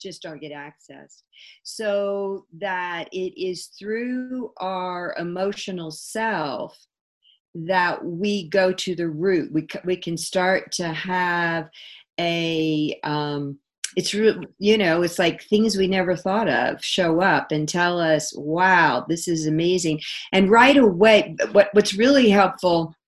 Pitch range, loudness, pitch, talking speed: 165-200 Hz, -21 LUFS, 180 Hz, 140 wpm